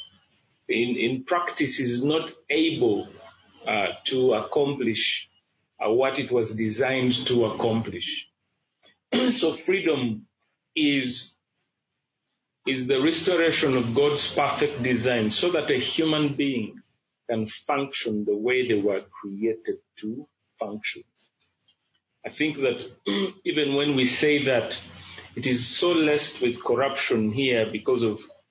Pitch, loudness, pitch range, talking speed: 130 Hz, -24 LUFS, 120-155 Hz, 120 wpm